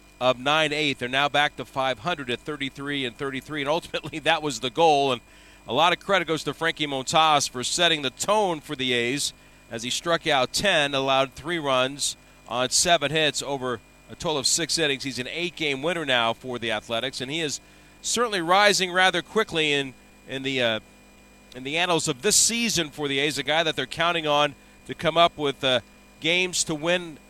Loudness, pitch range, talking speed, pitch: -23 LUFS, 130-165 Hz, 200 wpm, 145 Hz